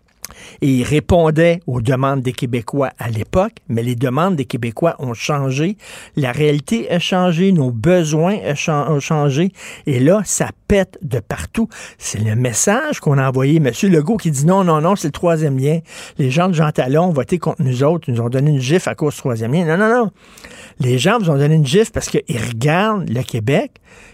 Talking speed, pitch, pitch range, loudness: 205 wpm, 155 Hz, 135-180 Hz, -16 LUFS